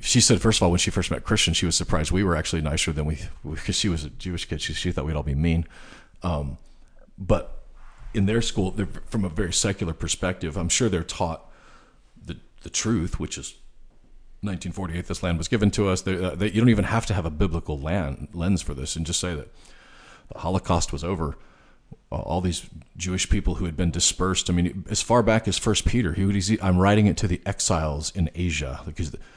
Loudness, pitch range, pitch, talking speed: -24 LUFS, 80-100 Hz, 90 Hz, 225 wpm